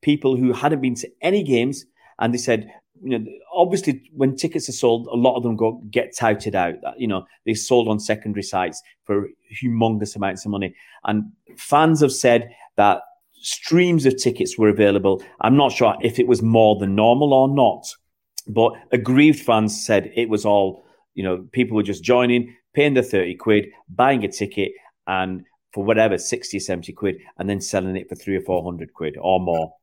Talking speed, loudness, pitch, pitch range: 195 wpm, -20 LUFS, 115 Hz, 100-130 Hz